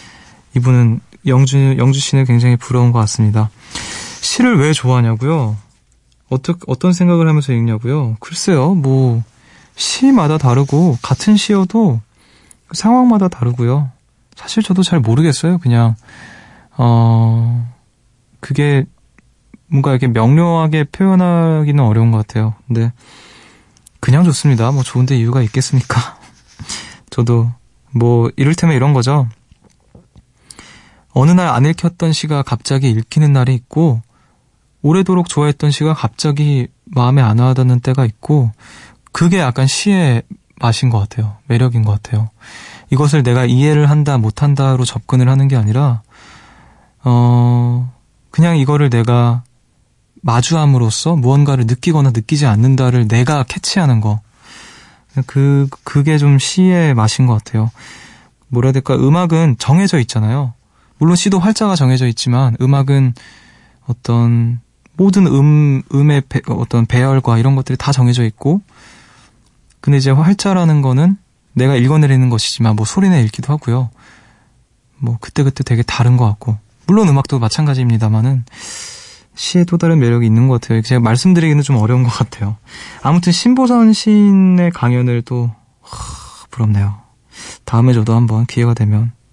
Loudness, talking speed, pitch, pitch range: -13 LUFS, 295 characters per minute, 130 Hz, 120-150 Hz